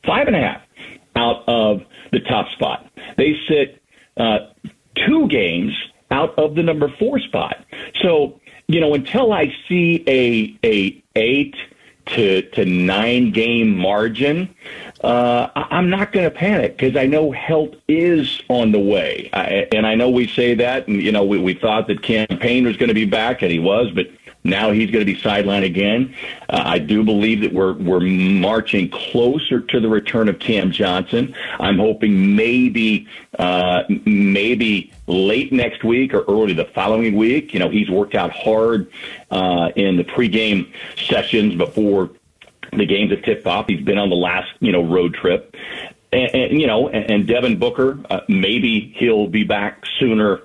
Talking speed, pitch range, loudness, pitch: 170 wpm, 100-130 Hz, -17 LUFS, 110 Hz